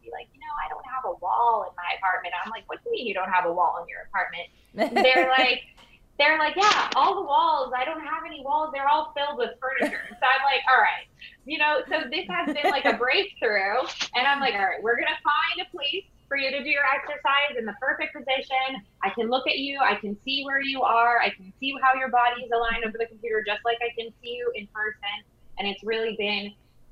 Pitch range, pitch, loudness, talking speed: 230-300 Hz, 265 Hz, -24 LUFS, 250 wpm